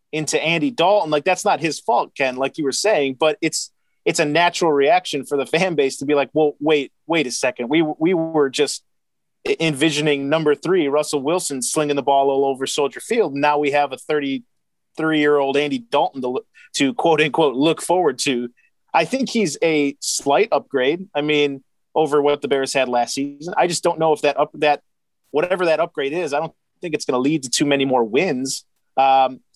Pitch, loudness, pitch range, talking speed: 150 Hz, -19 LUFS, 140-160 Hz, 215 wpm